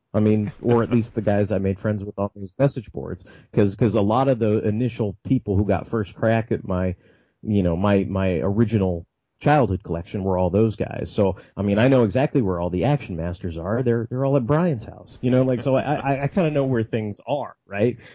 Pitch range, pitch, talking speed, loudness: 100-125 Hz, 110 Hz, 235 wpm, -22 LUFS